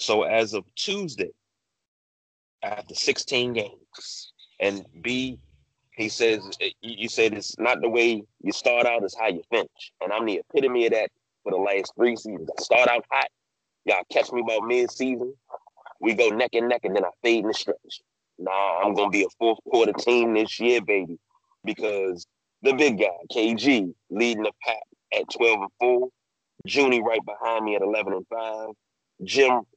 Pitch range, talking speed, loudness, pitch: 110-125 Hz, 175 wpm, -24 LUFS, 115 Hz